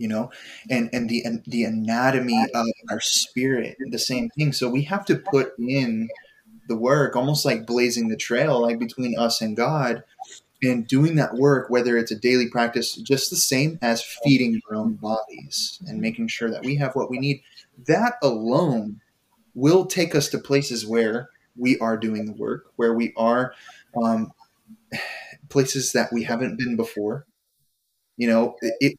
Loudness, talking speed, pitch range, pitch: -23 LUFS, 175 wpm, 115-140 Hz, 125 Hz